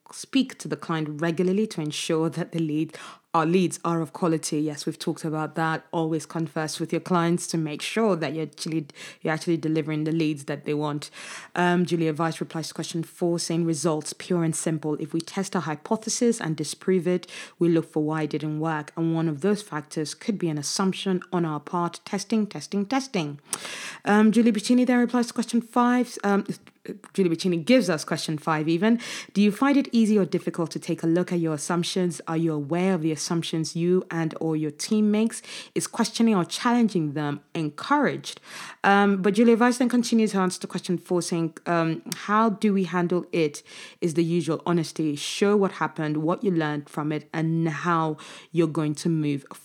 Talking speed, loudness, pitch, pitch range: 200 wpm, -25 LUFS, 170 Hz, 160-195 Hz